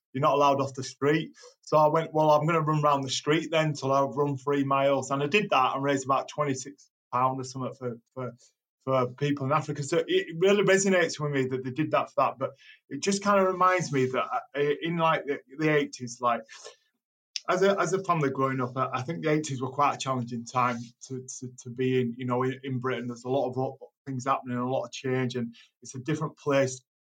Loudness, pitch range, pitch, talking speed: -27 LUFS, 130-155 Hz, 135 Hz, 235 wpm